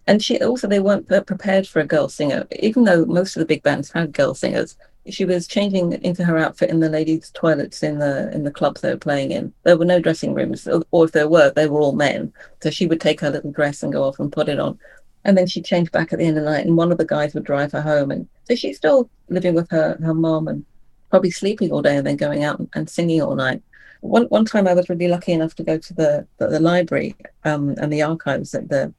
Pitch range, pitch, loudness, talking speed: 150-185 Hz, 165 Hz, -19 LUFS, 265 wpm